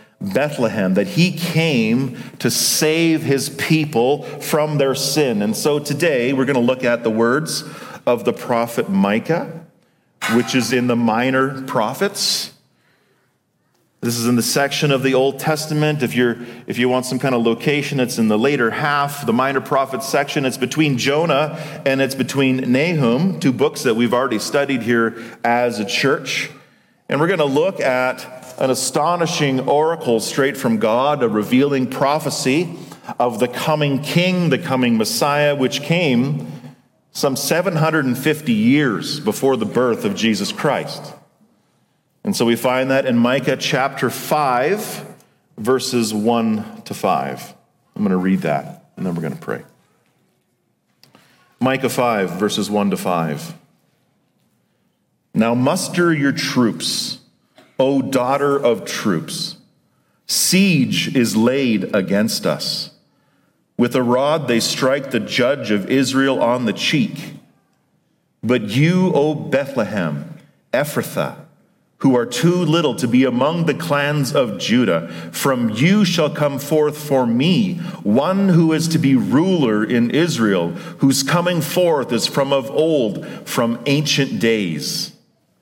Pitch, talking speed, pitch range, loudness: 135 Hz, 145 wpm, 125-155 Hz, -18 LUFS